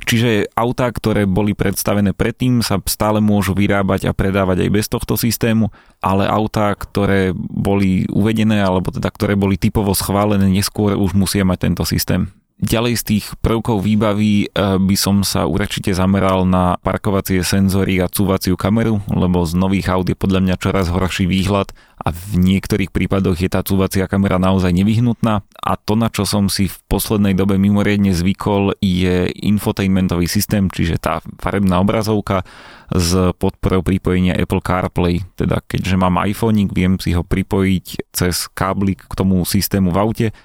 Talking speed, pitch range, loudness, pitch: 160 wpm, 95-105 Hz, -17 LUFS, 95 Hz